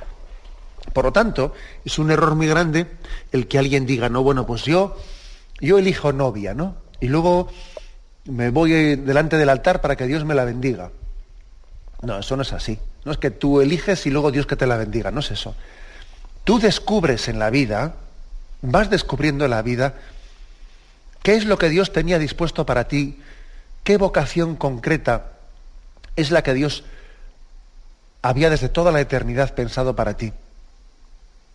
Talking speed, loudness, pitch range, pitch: 165 wpm, -20 LUFS, 115-160 Hz, 140 Hz